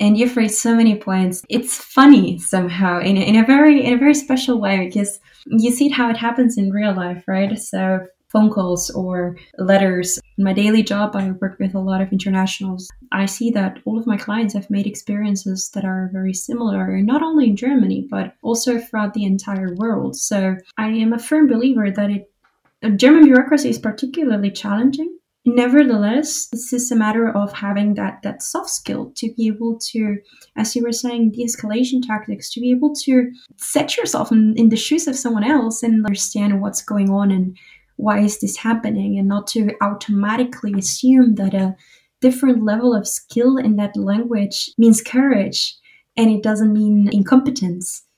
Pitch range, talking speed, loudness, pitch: 200-245 Hz, 185 wpm, -17 LUFS, 215 Hz